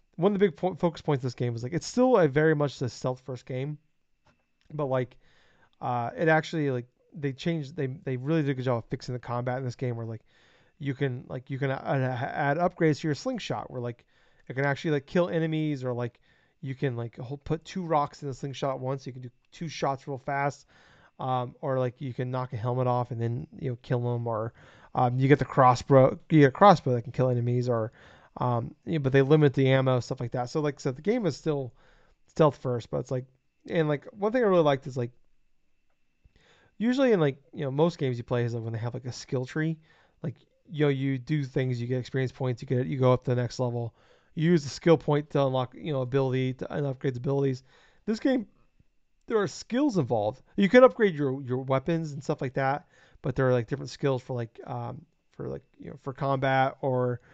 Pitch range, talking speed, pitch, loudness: 125-155 Hz, 240 wpm, 135 Hz, -28 LUFS